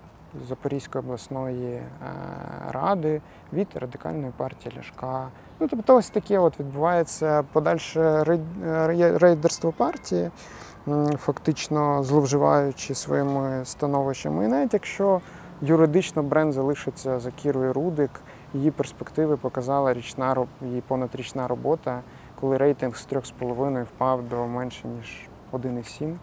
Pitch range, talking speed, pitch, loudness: 130-160 Hz, 100 wpm, 140 Hz, -25 LUFS